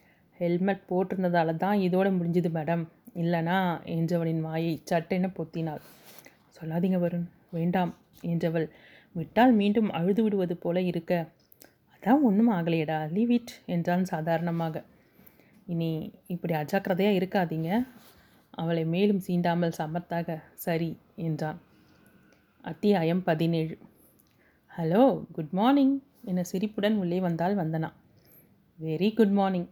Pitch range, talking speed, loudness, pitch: 165-195 Hz, 100 wpm, -28 LUFS, 175 Hz